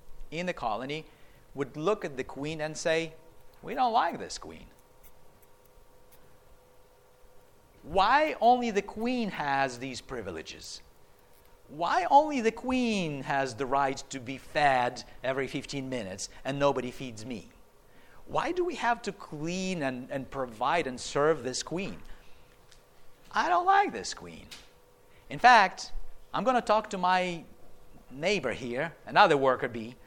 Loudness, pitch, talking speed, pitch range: -29 LUFS, 150 Hz, 140 wpm, 135-200 Hz